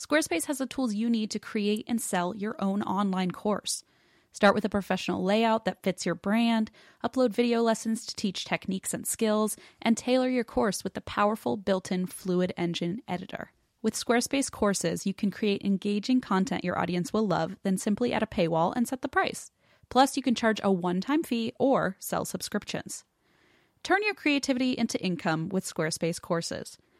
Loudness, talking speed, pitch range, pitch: -28 LUFS, 185 wpm, 185-240 Hz, 215 Hz